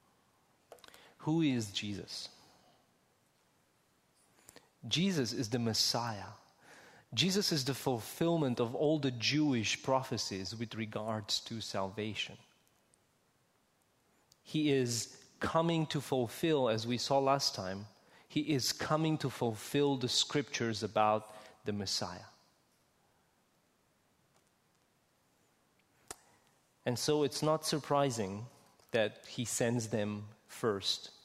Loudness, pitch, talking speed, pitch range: -34 LUFS, 120 Hz, 95 wpm, 110-145 Hz